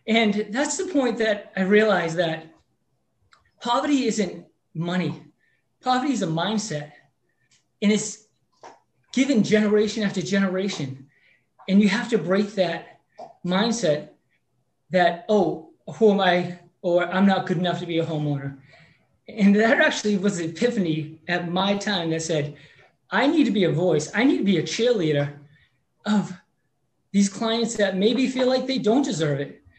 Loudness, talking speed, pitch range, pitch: -23 LUFS, 155 wpm, 165-220 Hz, 195 Hz